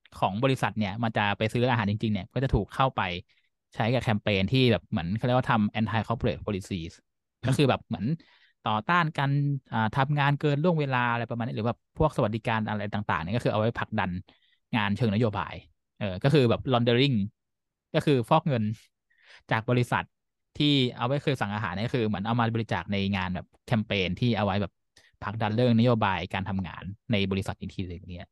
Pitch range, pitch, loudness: 100-125 Hz, 115 Hz, -27 LUFS